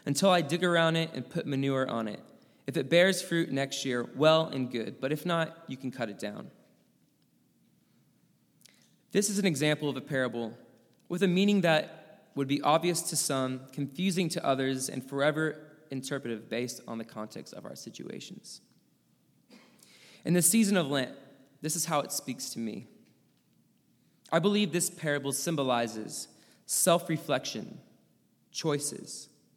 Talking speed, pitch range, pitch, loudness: 155 wpm, 130-170 Hz, 145 Hz, -30 LUFS